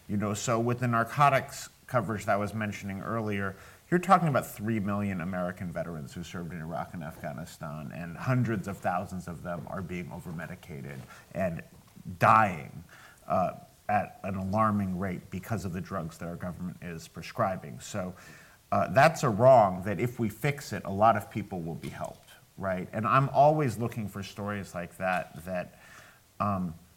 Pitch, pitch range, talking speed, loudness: 100 Hz, 90-115 Hz, 175 wpm, -29 LUFS